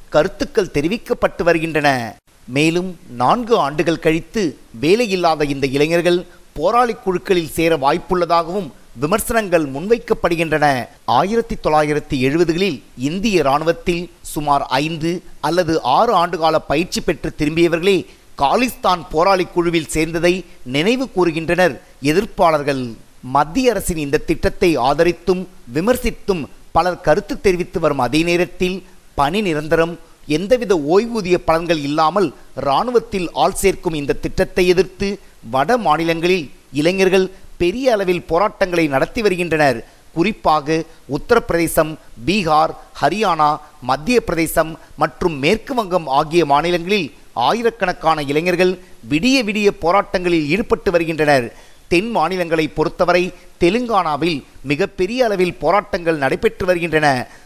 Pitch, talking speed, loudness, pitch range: 175 Hz, 100 wpm, -17 LUFS, 155-190 Hz